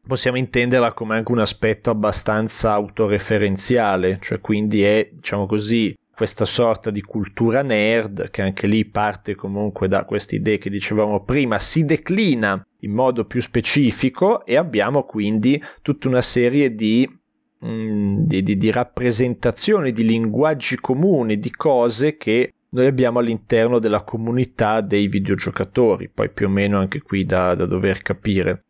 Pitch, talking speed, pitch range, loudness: 110 Hz, 145 wpm, 105-125 Hz, -19 LUFS